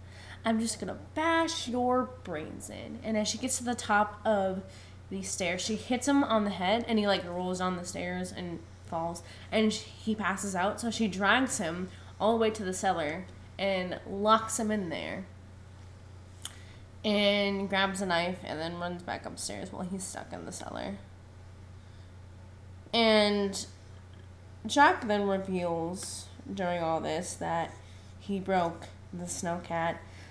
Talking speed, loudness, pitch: 160 wpm, -31 LUFS, 175 Hz